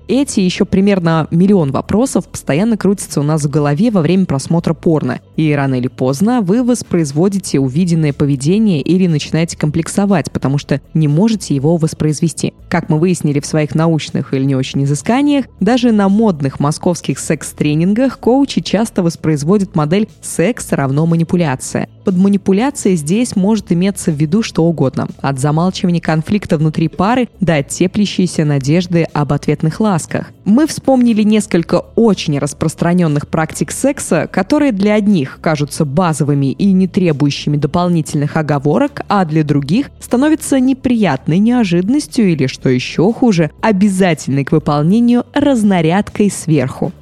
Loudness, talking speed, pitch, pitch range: -14 LUFS, 135 wpm, 175 Hz, 150-205 Hz